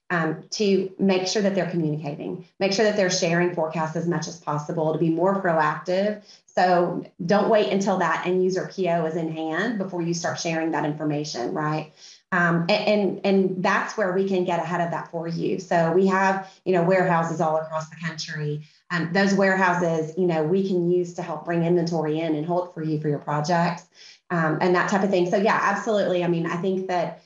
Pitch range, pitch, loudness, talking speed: 160-190 Hz, 175 Hz, -23 LUFS, 215 wpm